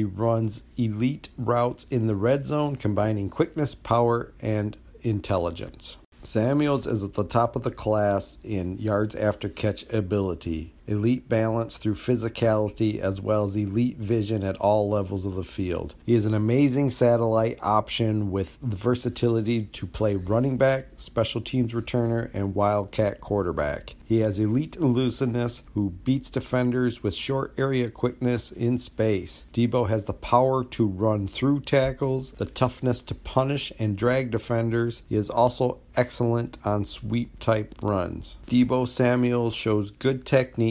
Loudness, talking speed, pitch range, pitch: -25 LUFS, 150 wpm, 105-125 Hz, 115 Hz